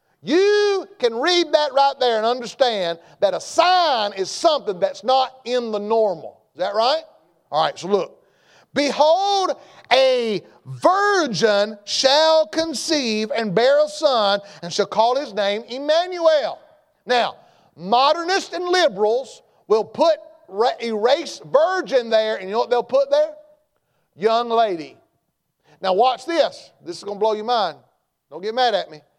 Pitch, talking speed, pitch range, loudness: 265 Hz, 150 wpm, 220-320 Hz, -19 LUFS